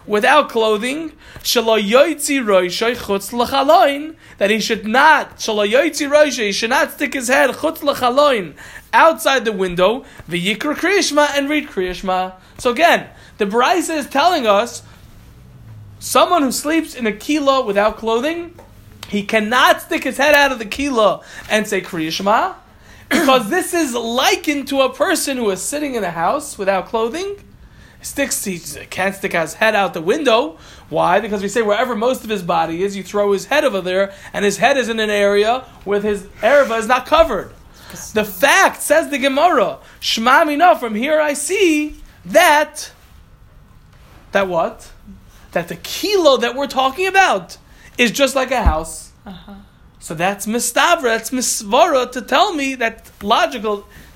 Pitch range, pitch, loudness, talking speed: 205-295 Hz, 245 Hz, -16 LUFS, 145 wpm